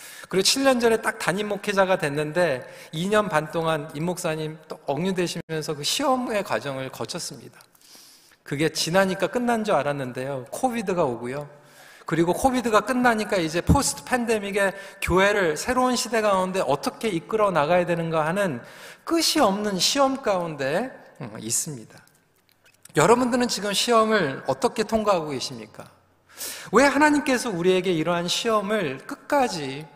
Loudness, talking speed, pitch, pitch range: -23 LUFS, 320 characters per minute, 195 Hz, 160-230 Hz